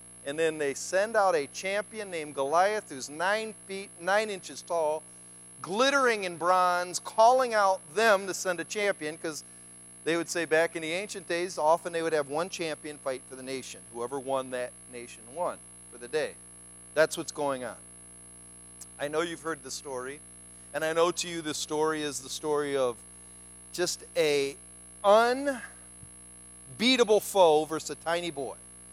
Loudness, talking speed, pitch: -29 LUFS, 170 wpm, 155 Hz